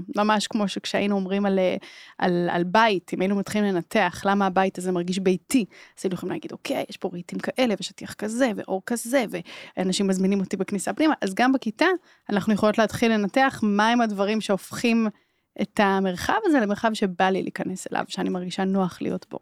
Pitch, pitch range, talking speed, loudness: 200 Hz, 190-225 Hz, 180 wpm, -24 LUFS